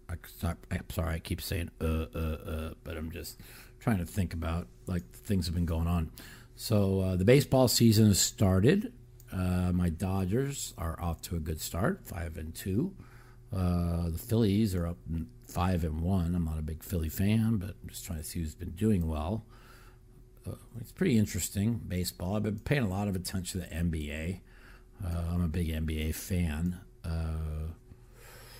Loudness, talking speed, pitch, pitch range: -31 LUFS, 180 wpm, 90 Hz, 85-115 Hz